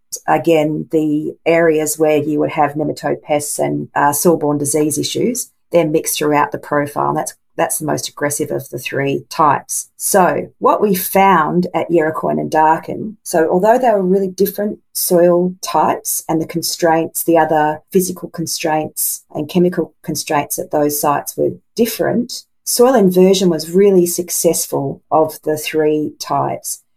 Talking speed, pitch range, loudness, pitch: 155 wpm, 150-180 Hz, -16 LUFS, 160 Hz